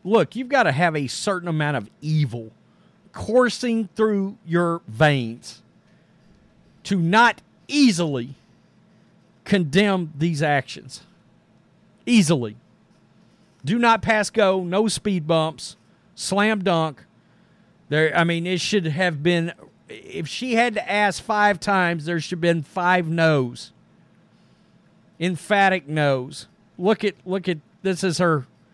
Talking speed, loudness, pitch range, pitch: 125 wpm, -21 LUFS, 160-205 Hz, 180 Hz